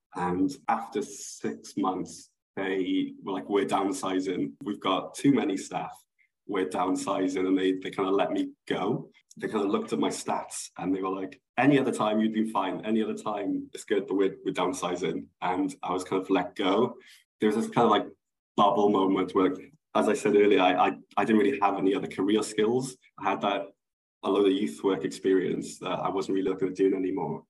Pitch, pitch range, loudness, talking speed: 100 Hz, 95-115 Hz, -28 LUFS, 210 wpm